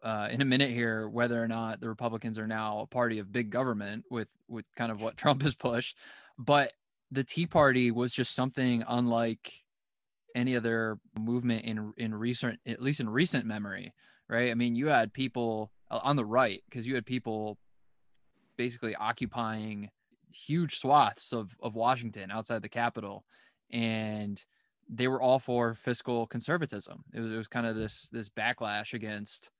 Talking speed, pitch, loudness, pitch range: 170 wpm, 115 Hz, -31 LUFS, 110-125 Hz